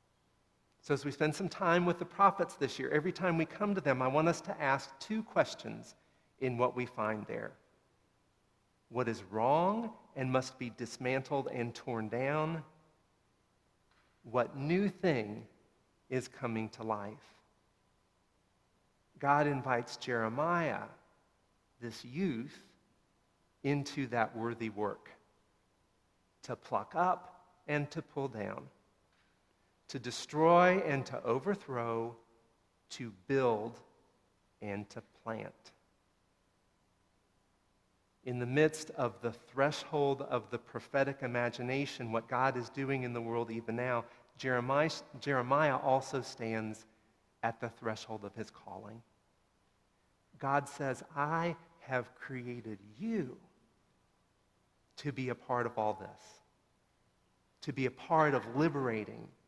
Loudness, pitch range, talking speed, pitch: -35 LUFS, 110-145 Hz, 120 wpm, 125 Hz